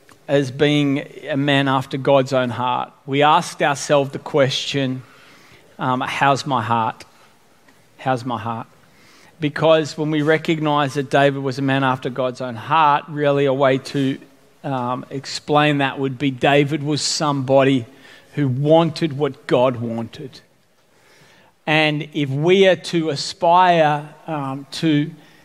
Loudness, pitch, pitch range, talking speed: -19 LUFS, 140 Hz, 135-150 Hz, 135 wpm